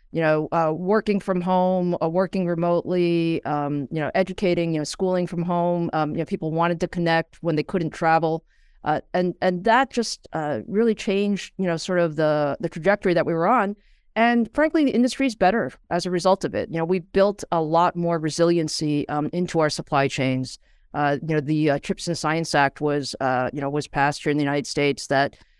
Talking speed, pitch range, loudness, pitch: 220 wpm, 150-185 Hz, -23 LUFS, 170 Hz